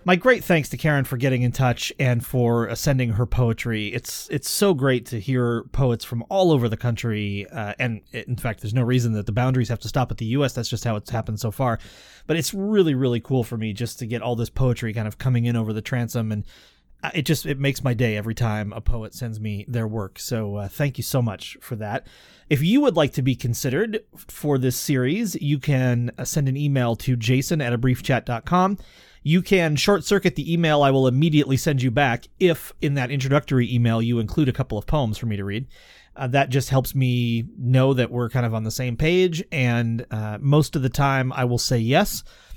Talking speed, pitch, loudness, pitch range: 230 wpm, 125 Hz, -22 LUFS, 115-145 Hz